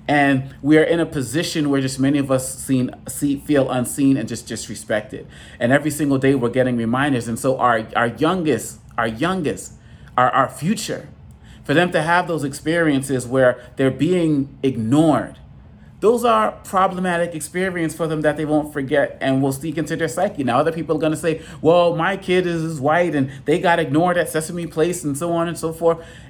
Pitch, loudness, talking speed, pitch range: 150 Hz, -19 LUFS, 195 wpm, 135-165 Hz